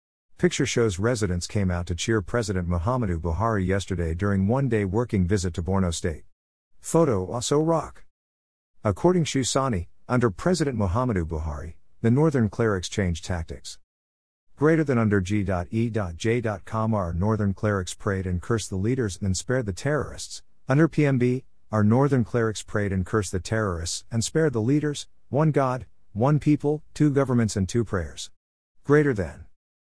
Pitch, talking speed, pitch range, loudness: 105 Hz, 150 wpm, 90-125 Hz, -25 LUFS